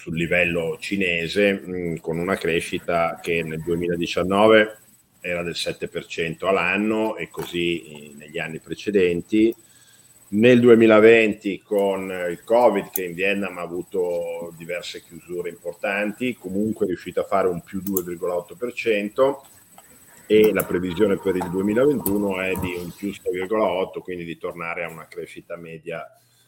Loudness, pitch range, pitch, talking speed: -22 LUFS, 85-110 Hz, 95 Hz, 130 wpm